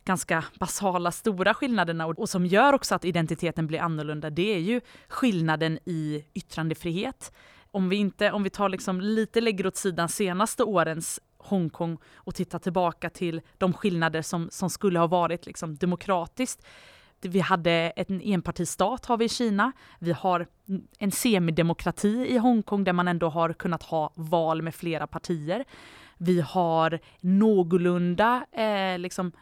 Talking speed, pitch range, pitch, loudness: 150 wpm, 170-205 Hz, 180 Hz, -26 LUFS